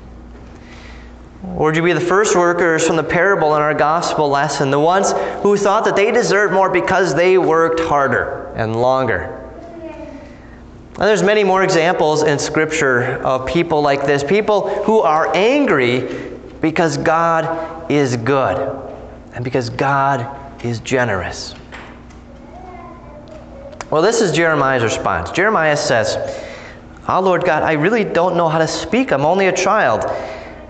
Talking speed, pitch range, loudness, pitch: 145 wpm, 130-185 Hz, -15 LUFS, 160 Hz